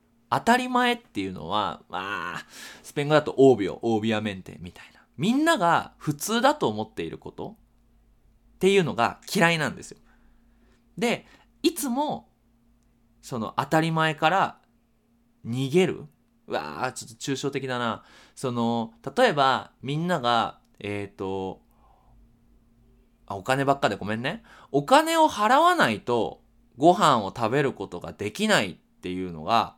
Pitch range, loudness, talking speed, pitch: 115-160 Hz, -25 LUFS, 280 characters per minute, 120 Hz